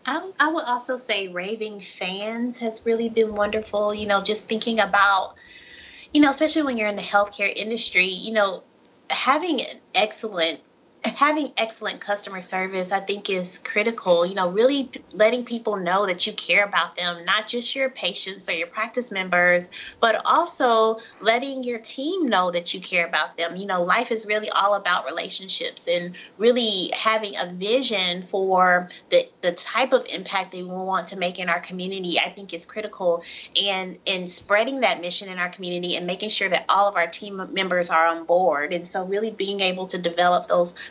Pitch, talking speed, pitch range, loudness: 200 Hz, 190 wpm, 180-225 Hz, -22 LUFS